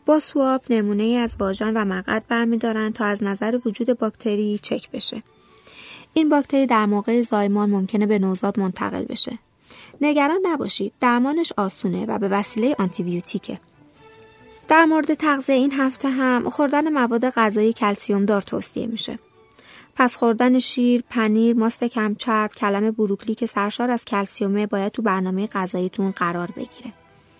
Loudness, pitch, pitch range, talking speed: -20 LUFS, 220 Hz, 205-250 Hz, 145 wpm